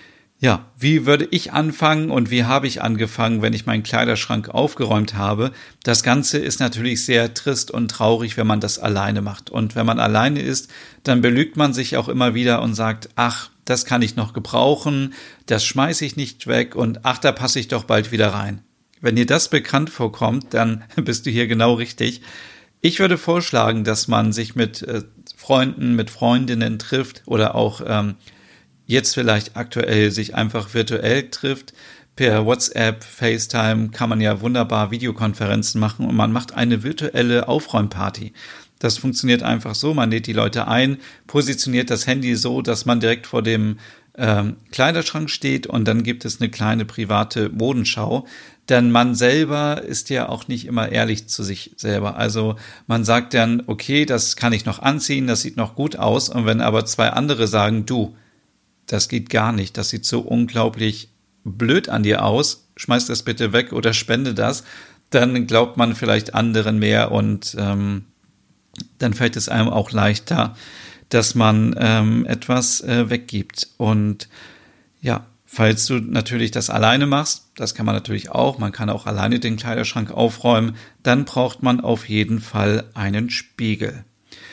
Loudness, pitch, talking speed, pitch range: -19 LUFS, 115 Hz, 170 wpm, 110-125 Hz